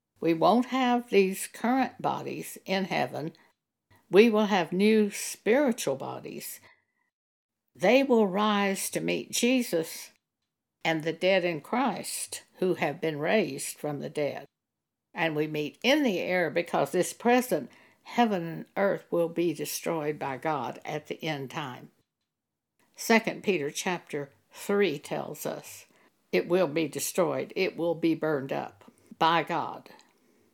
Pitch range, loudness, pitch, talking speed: 160-215 Hz, -28 LUFS, 175 Hz, 140 wpm